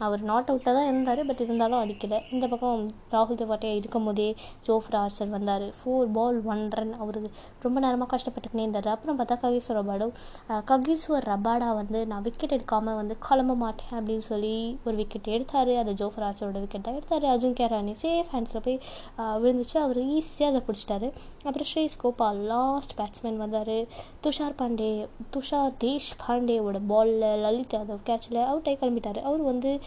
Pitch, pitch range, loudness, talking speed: 230 Hz, 215-255 Hz, -28 LUFS, 155 wpm